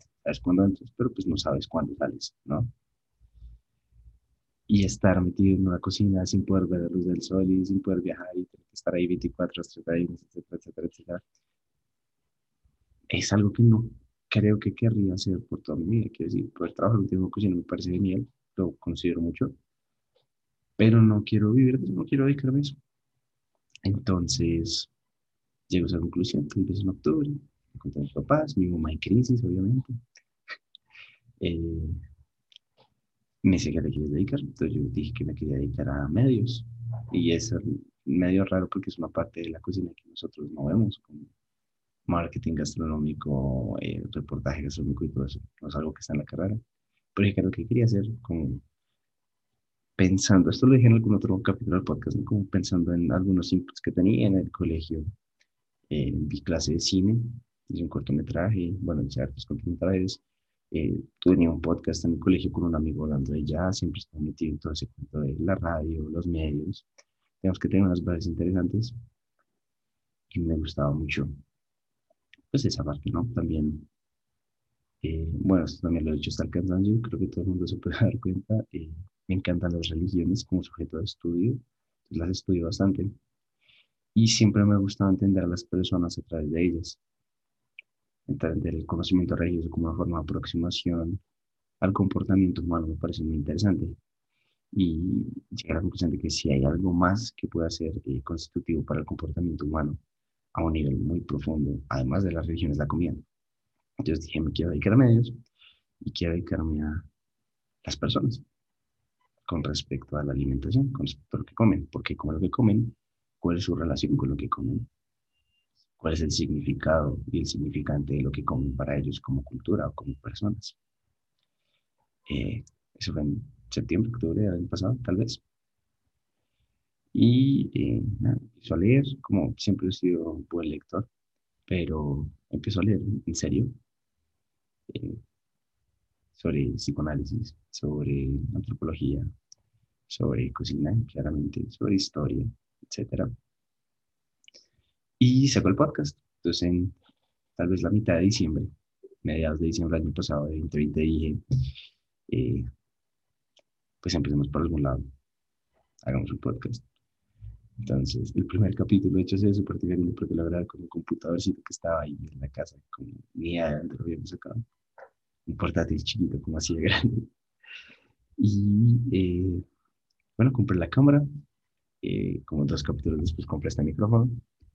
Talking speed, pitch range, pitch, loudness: 165 wpm, 80-105 Hz, 90 Hz, -27 LUFS